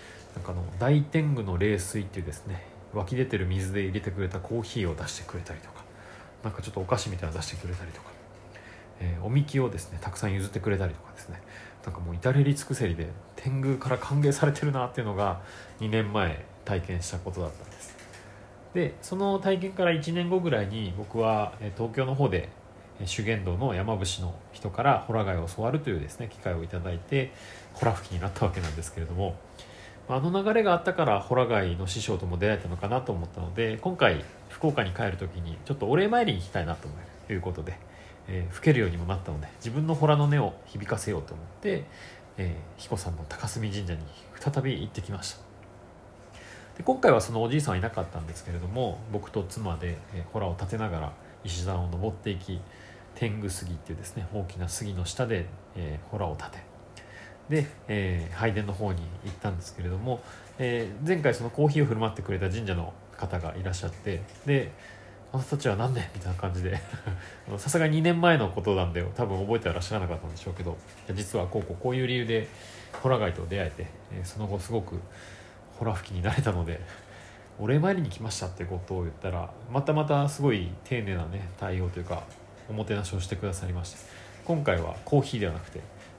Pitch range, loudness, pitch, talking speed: 90-115 Hz, -30 LUFS, 100 Hz, 405 characters per minute